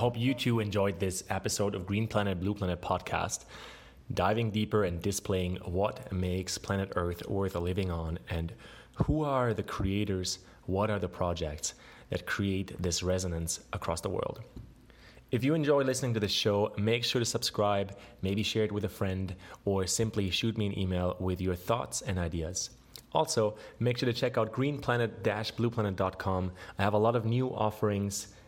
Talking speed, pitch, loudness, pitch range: 175 wpm, 100 Hz, -32 LUFS, 95-115 Hz